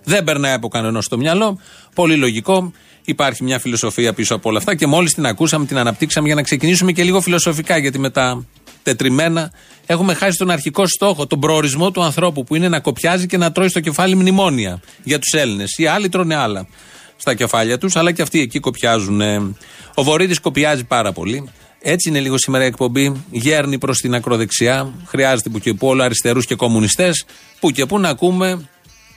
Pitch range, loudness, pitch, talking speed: 125-175 Hz, -16 LUFS, 150 Hz, 185 wpm